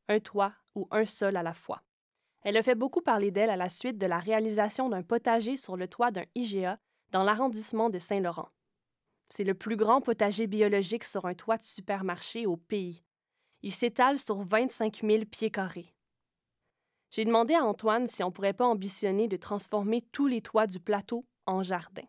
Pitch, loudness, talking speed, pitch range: 215 Hz, -30 LUFS, 190 wpm, 195-230 Hz